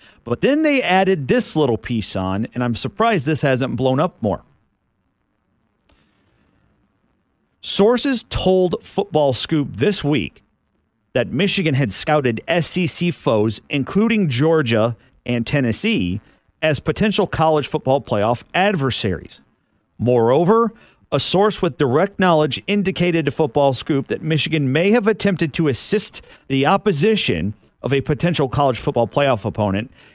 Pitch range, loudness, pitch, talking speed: 125-185 Hz, -18 LUFS, 150 Hz, 125 wpm